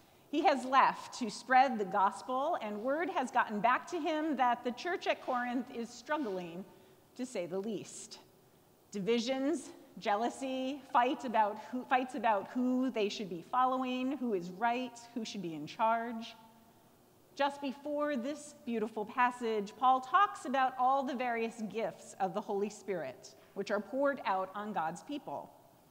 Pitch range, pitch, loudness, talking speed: 210-270 Hz, 245 Hz, -34 LUFS, 160 wpm